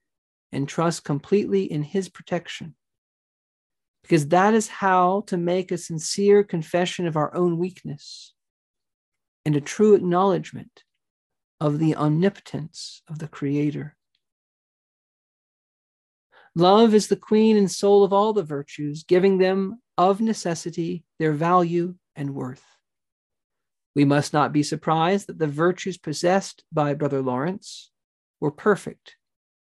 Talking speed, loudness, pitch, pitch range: 125 wpm, -22 LUFS, 175 Hz, 150-195 Hz